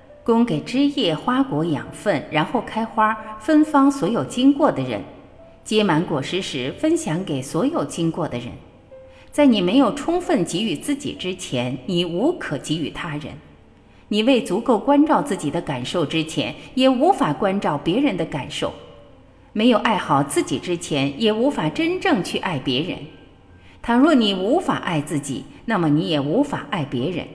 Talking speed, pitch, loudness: 240 characters per minute, 215 Hz, -21 LUFS